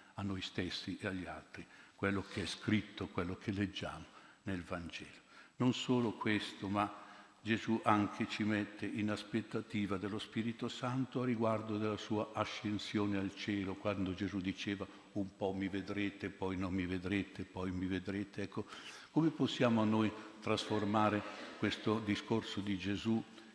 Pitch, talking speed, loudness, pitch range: 105 Hz, 150 wpm, -38 LUFS, 100-110 Hz